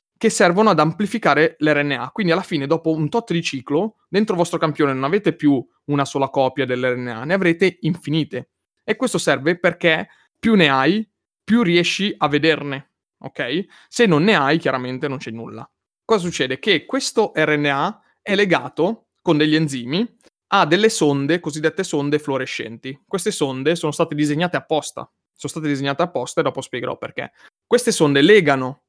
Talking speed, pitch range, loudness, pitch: 165 wpm, 140-190 Hz, -19 LUFS, 155 Hz